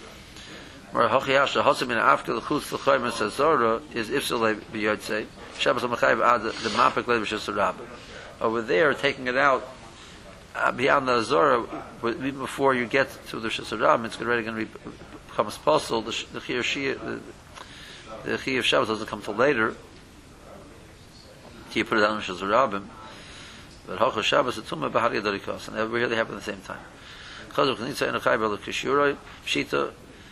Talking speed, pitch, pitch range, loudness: 165 wpm, 110 Hz, 105-120 Hz, -25 LUFS